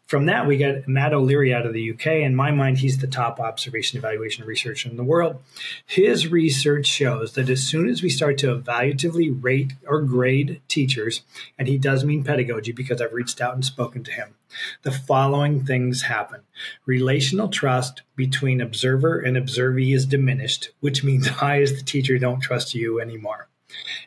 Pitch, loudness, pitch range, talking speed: 135 Hz, -22 LUFS, 125-145 Hz, 180 wpm